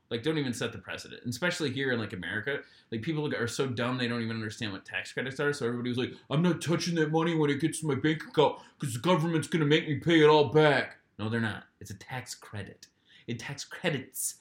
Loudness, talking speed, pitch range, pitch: -29 LUFS, 255 wpm, 120-160 Hz, 140 Hz